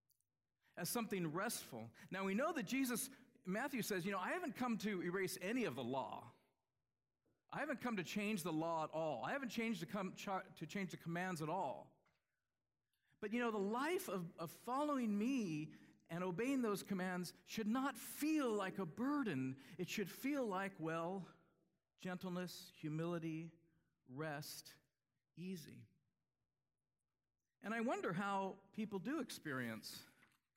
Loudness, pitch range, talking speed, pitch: -44 LUFS, 165-230 Hz, 150 wpm, 190 Hz